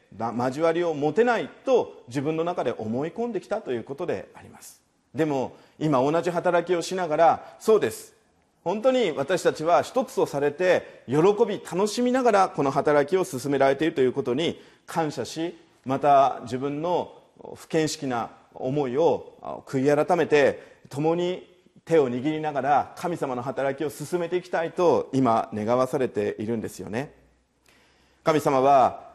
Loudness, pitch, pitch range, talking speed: -24 LUFS, 165 Hz, 140-195 Hz, 305 characters per minute